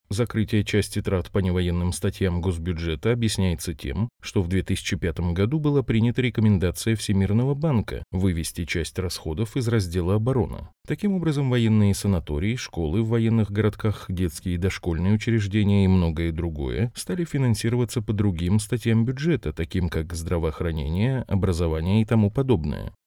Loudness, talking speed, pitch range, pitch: -24 LUFS, 135 wpm, 90-115 Hz, 100 Hz